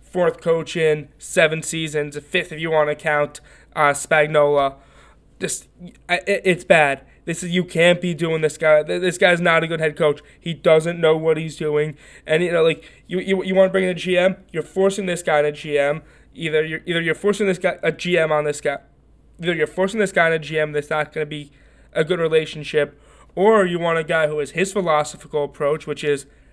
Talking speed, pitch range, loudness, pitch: 220 wpm, 150-175 Hz, -20 LUFS, 160 Hz